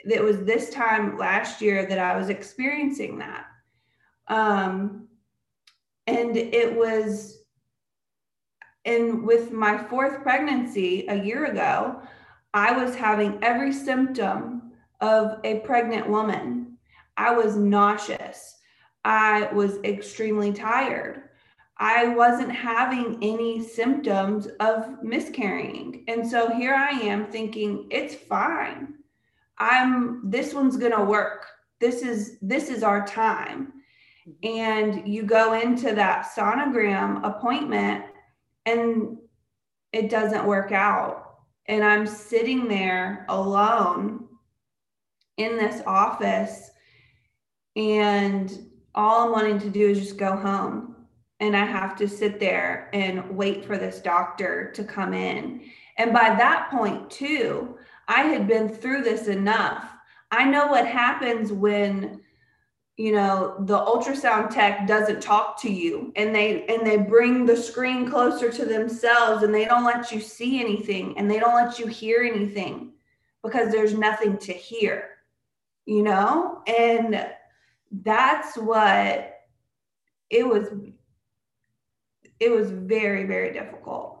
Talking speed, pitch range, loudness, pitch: 125 wpm, 205-235 Hz, -23 LUFS, 220 Hz